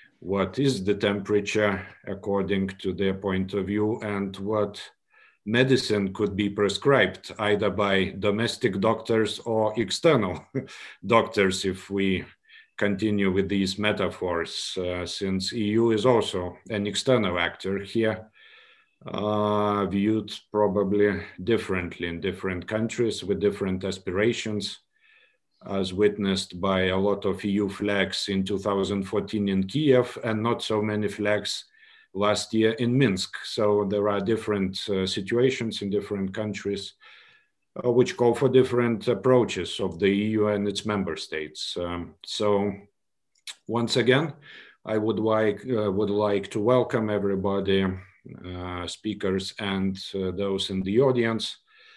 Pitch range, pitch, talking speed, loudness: 95-110 Hz, 105 Hz, 130 wpm, -25 LUFS